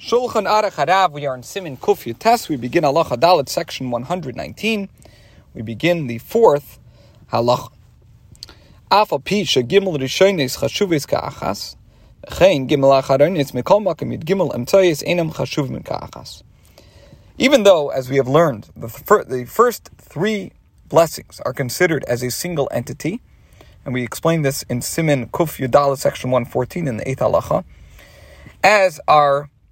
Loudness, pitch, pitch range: -18 LUFS, 140 Hz, 120-175 Hz